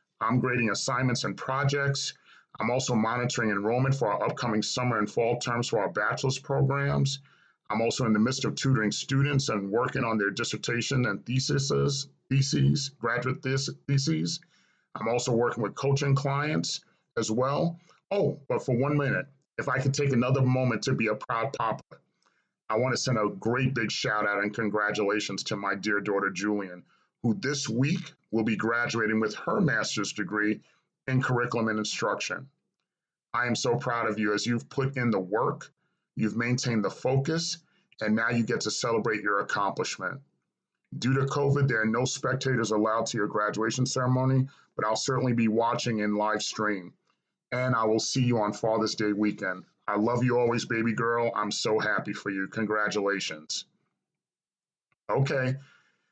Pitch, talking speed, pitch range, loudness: 120 Hz, 170 wpm, 110-135 Hz, -28 LUFS